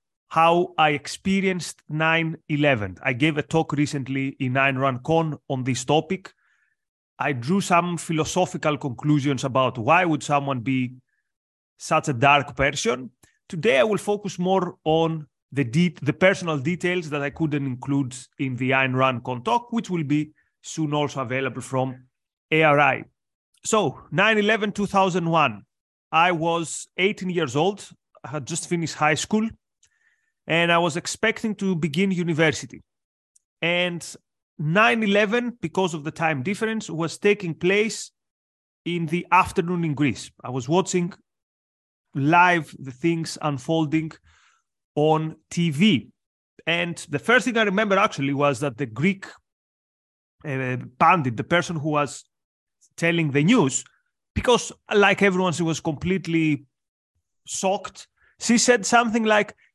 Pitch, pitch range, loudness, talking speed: 160 Hz, 140-185 Hz, -22 LUFS, 135 wpm